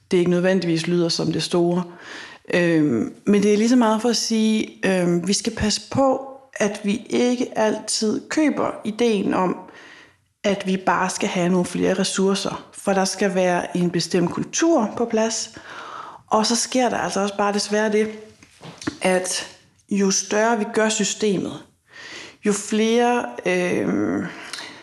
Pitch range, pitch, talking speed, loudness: 190-235 Hz, 210 Hz, 160 wpm, -21 LUFS